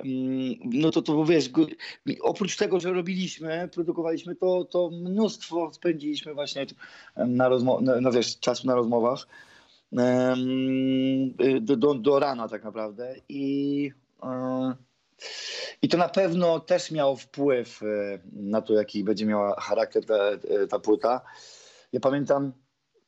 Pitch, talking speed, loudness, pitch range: 140 Hz, 120 wpm, -26 LUFS, 130-180 Hz